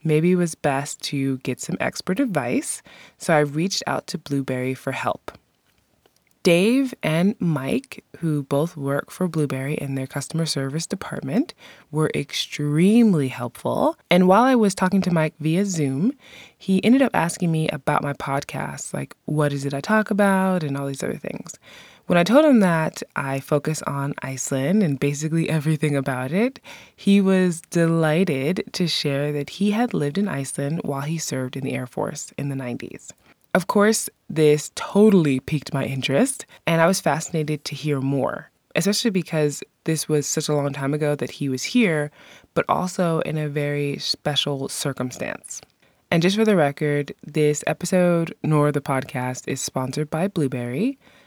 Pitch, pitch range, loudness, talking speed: 155 Hz, 140-185 Hz, -22 LUFS, 170 wpm